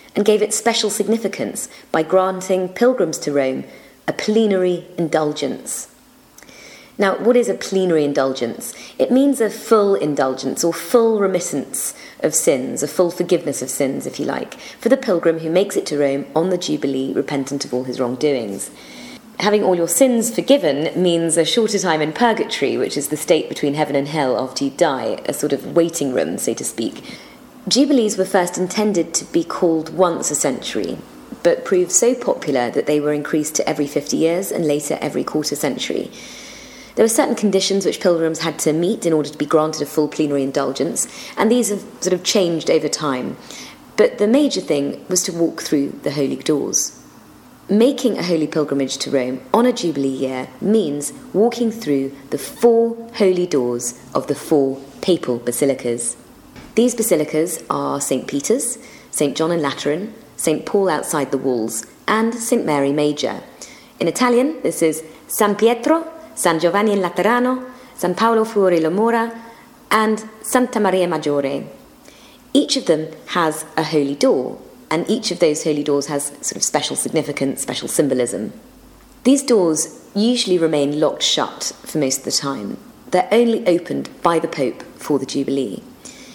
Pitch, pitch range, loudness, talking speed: 175 Hz, 145-220 Hz, -18 LUFS, 170 wpm